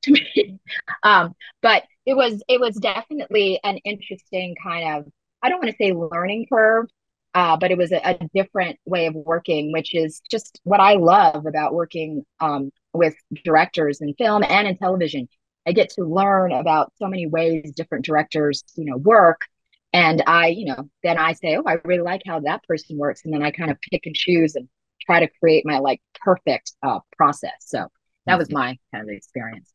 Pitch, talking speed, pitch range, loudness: 170 Hz, 195 wpm, 155-195 Hz, -20 LUFS